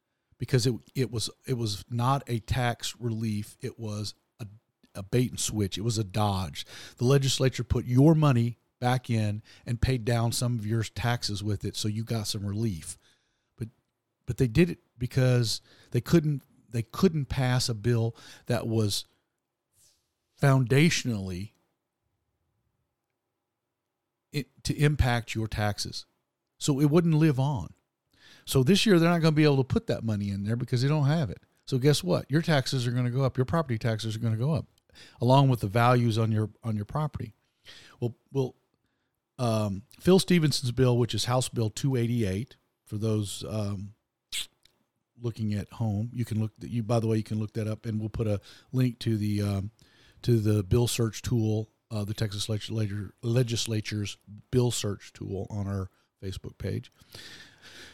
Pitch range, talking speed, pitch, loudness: 110-130 Hz, 175 wpm, 115 Hz, -28 LUFS